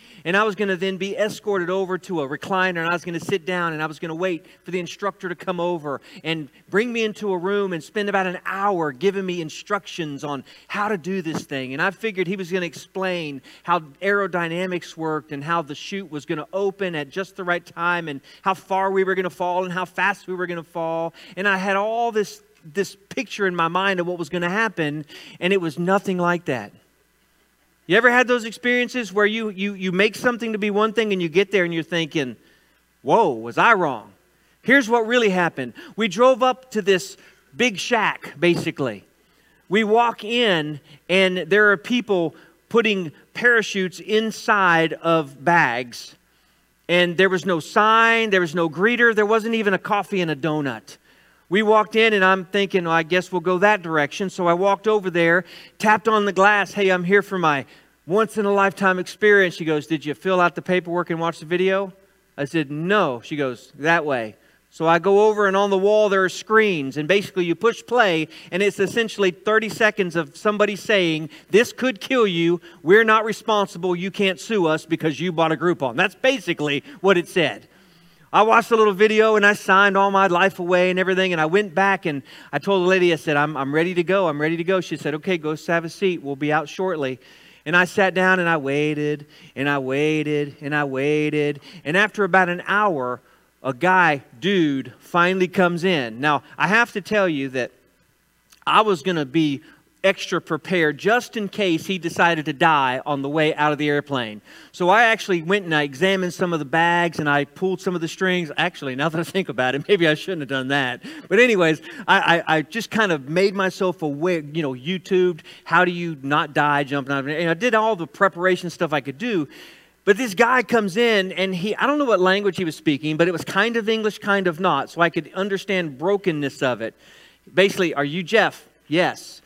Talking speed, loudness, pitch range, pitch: 220 wpm, -20 LUFS, 160-200 Hz, 180 Hz